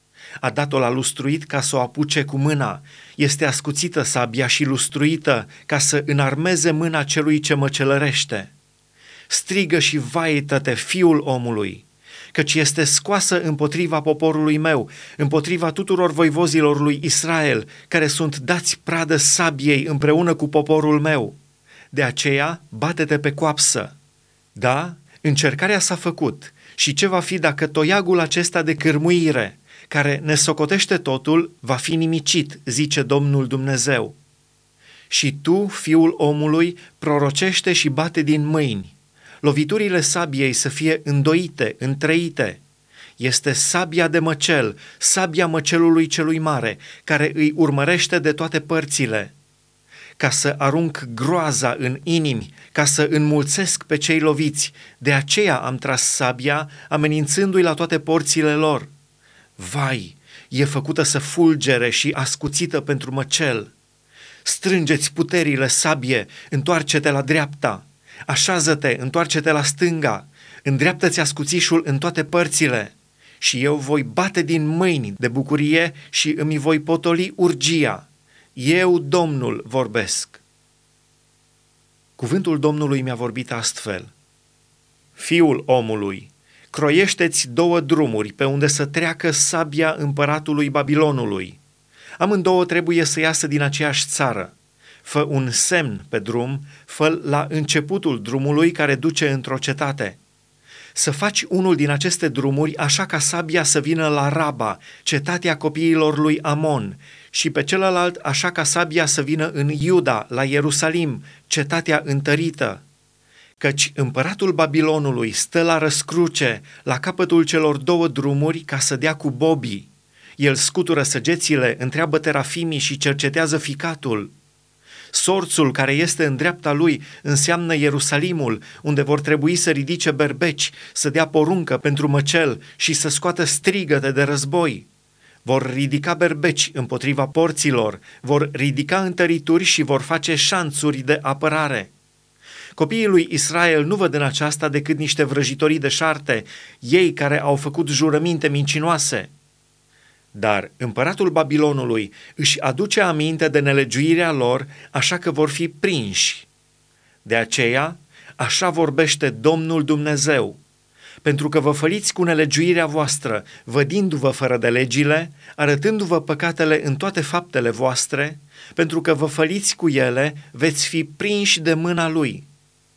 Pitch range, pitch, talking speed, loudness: 140-165 Hz, 150 Hz, 125 wpm, -19 LUFS